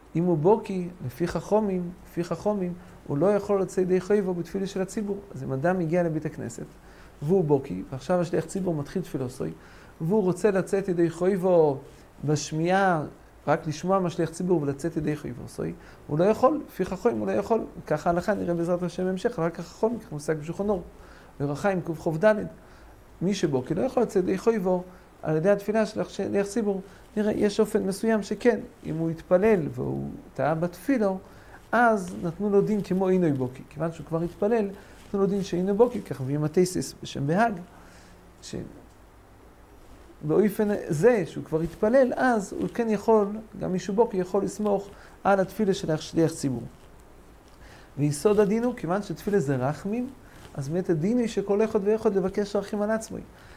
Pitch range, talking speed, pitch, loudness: 160-210 Hz, 155 wpm, 185 Hz, -26 LUFS